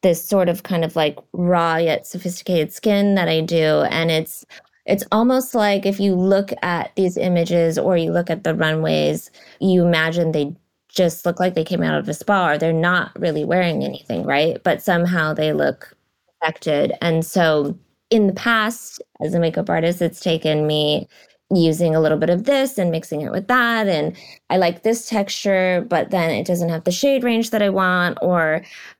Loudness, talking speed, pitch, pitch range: -19 LUFS, 195 wpm, 175 Hz, 160-195 Hz